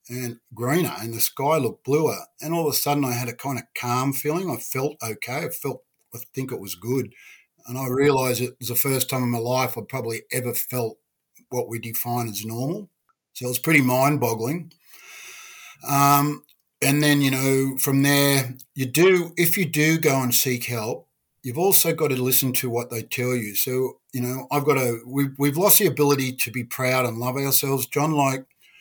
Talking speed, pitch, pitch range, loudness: 210 wpm, 130 Hz, 120-145 Hz, -22 LUFS